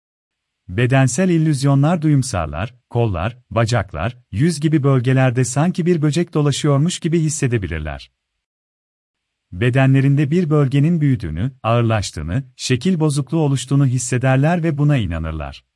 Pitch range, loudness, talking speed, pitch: 95-150 Hz, -18 LUFS, 100 wpm, 130 Hz